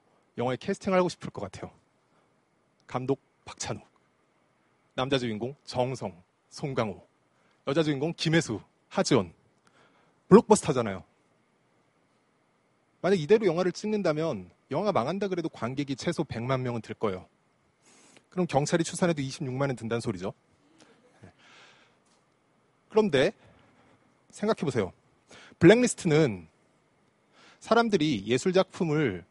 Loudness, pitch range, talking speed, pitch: -28 LUFS, 120-180 Hz, 250 characters per minute, 150 Hz